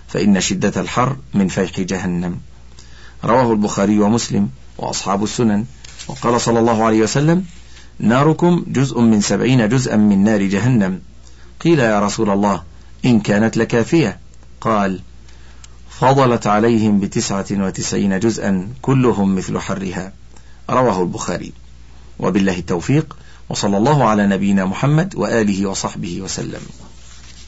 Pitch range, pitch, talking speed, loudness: 90-120 Hz, 100 Hz, 115 wpm, -16 LUFS